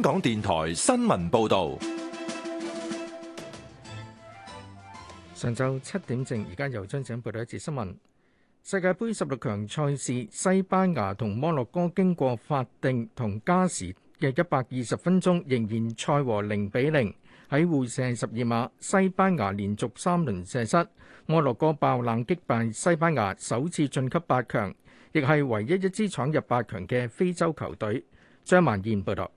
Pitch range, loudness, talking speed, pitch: 110-175 Hz, -27 LUFS, 225 characters per minute, 130 Hz